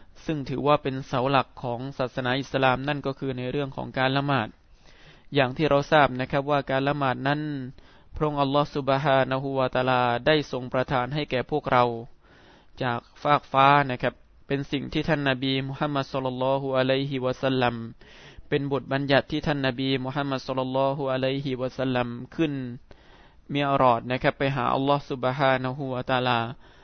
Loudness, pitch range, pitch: -25 LUFS, 130-140 Hz, 135 Hz